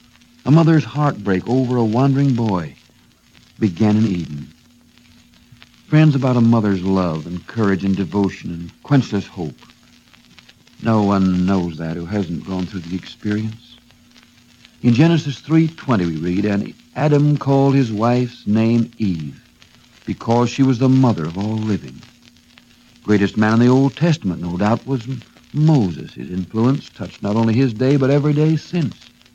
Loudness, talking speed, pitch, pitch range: -18 LUFS, 150 wpm, 115 Hz, 95-130 Hz